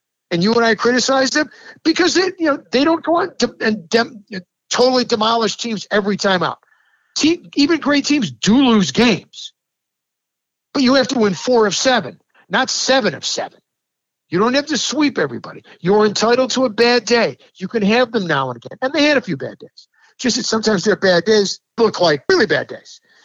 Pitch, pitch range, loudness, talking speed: 235 Hz, 210-275 Hz, -16 LUFS, 200 wpm